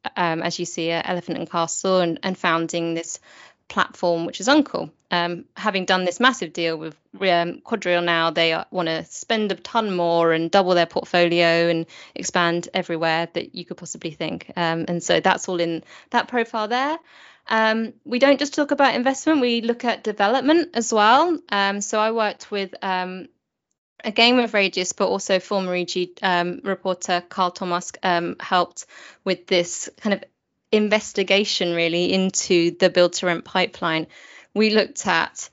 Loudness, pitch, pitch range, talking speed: -21 LUFS, 185 Hz, 170-215 Hz, 170 wpm